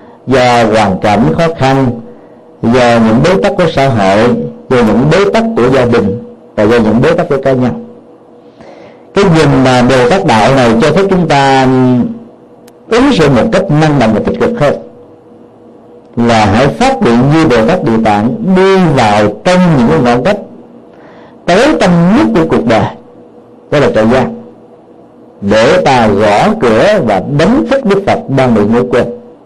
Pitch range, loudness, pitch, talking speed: 120-180 Hz, -8 LUFS, 135 Hz, 175 wpm